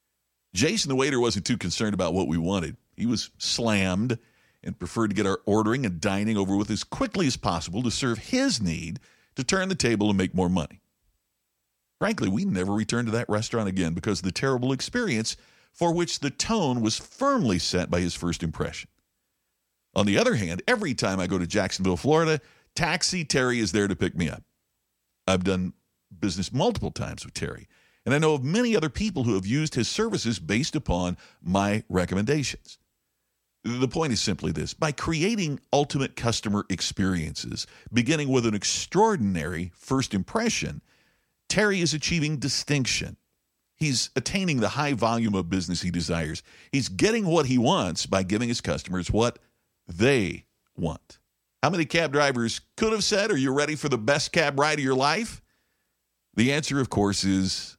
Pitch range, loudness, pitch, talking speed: 95-145 Hz, -26 LUFS, 115 Hz, 175 wpm